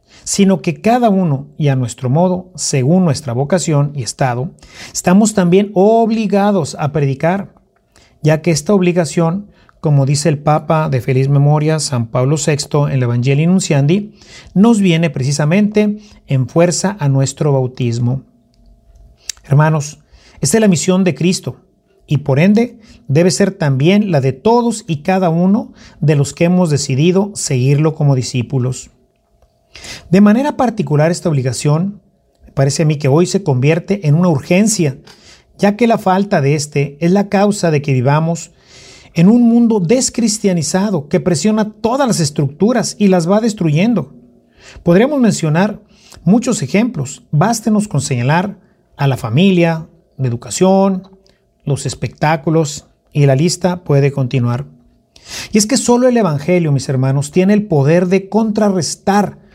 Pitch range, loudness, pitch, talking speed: 140-195 Hz, -14 LUFS, 170 Hz, 145 wpm